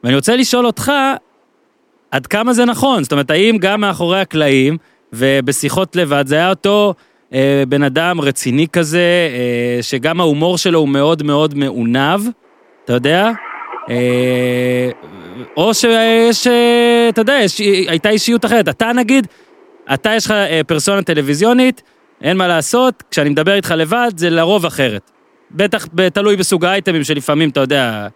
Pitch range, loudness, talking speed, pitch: 145-220 Hz, -13 LUFS, 145 wpm, 175 Hz